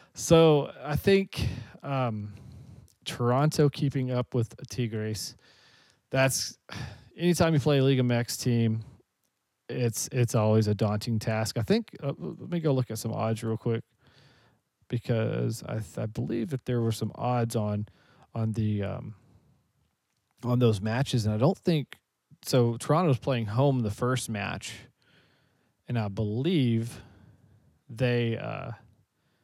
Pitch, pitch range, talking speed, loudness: 120 Hz, 110-135 Hz, 140 wpm, -28 LUFS